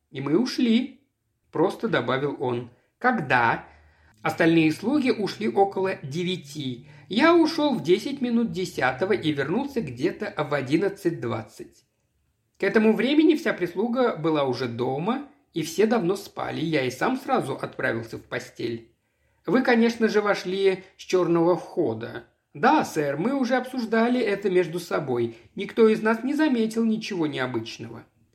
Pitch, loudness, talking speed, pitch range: 190 Hz, -24 LUFS, 140 wpm, 145-235 Hz